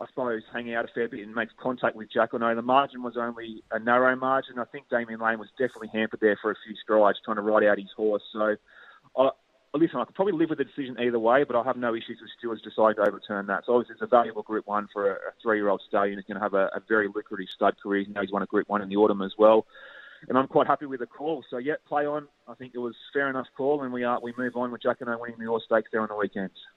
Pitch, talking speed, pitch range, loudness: 115 Hz, 295 wpm, 105-125 Hz, -27 LUFS